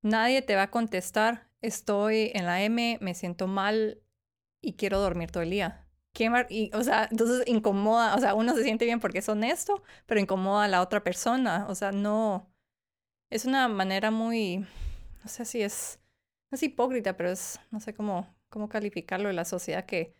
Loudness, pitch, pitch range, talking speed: -28 LUFS, 215 Hz, 190-230 Hz, 190 wpm